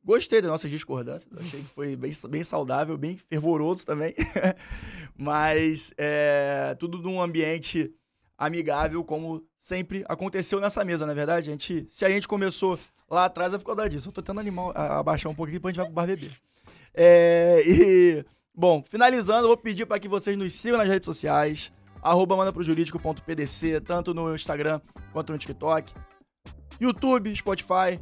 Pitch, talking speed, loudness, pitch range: 170 Hz, 165 wpm, -25 LUFS, 155-190 Hz